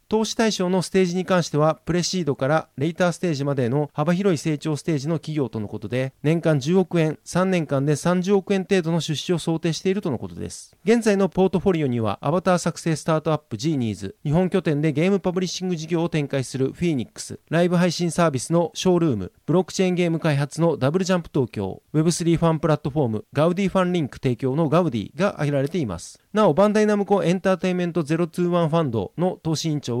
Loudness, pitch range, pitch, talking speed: -22 LUFS, 145-180 Hz, 165 Hz, 490 characters per minute